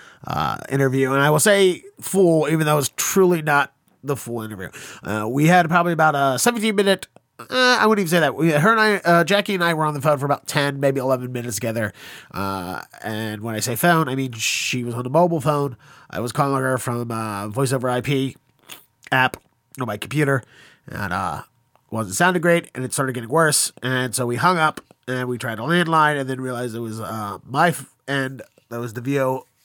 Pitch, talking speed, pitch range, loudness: 135 Hz, 220 wpm, 120-160 Hz, -20 LUFS